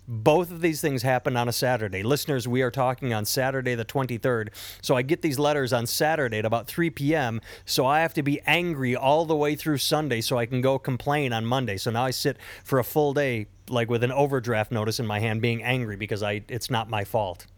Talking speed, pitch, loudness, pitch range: 235 wpm, 125 Hz, -25 LUFS, 115-145 Hz